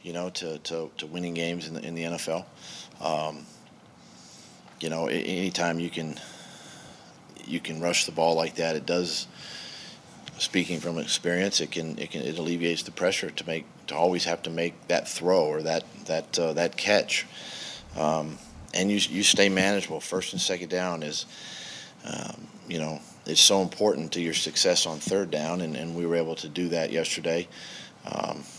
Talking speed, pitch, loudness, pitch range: 180 wpm, 85 Hz, -27 LUFS, 80-90 Hz